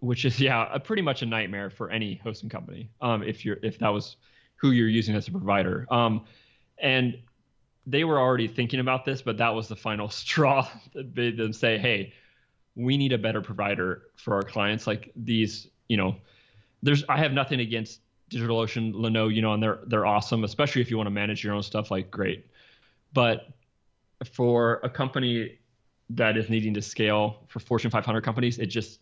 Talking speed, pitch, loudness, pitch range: 195 wpm, 115 Hz, -26 LUFS, 105-125 Hz